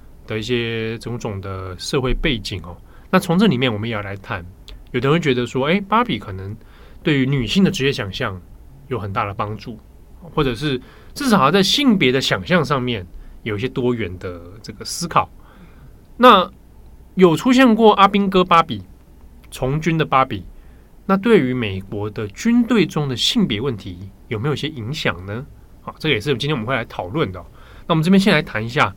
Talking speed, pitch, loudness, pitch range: 280 characters per minute, 125 Hz, -18 LUFS, 100-155 Hz